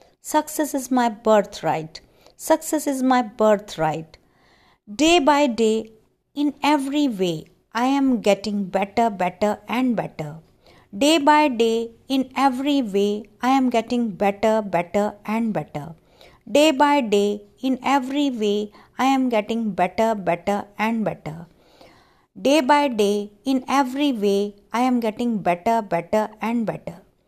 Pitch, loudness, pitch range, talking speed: 225 Hz, -21 LUFS, 205-270 Hz, 130 wpm